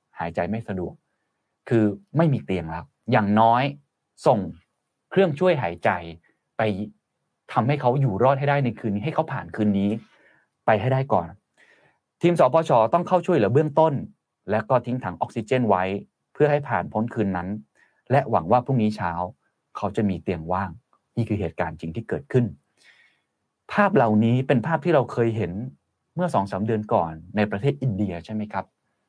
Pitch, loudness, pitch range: 110 Hz, -23 LUFS, 100-135 Hz